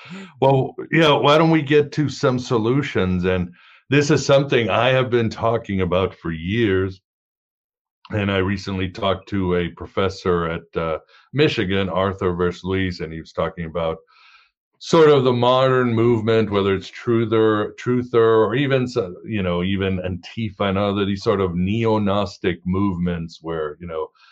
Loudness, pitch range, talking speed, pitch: -20 LUFS, 95-125 Hz, 160 wpm, 100 Hz